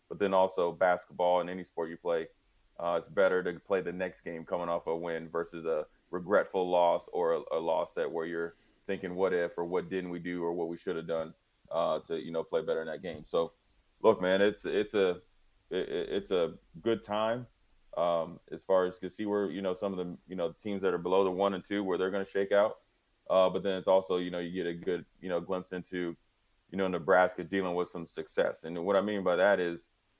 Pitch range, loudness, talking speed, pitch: 85-100 Hz, -32 LUFS, 245 wpm, 95 Hz